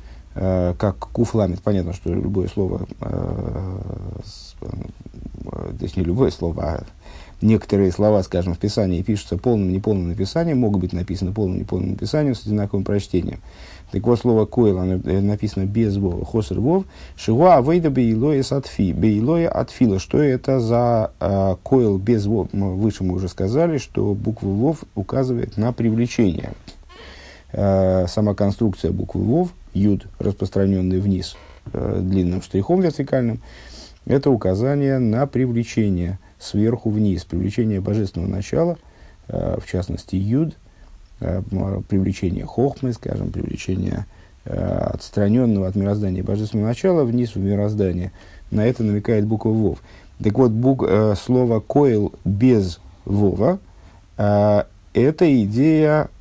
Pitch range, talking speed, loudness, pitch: 95-115 Hz, 130 wpm, -20 LUFS, 100 Hz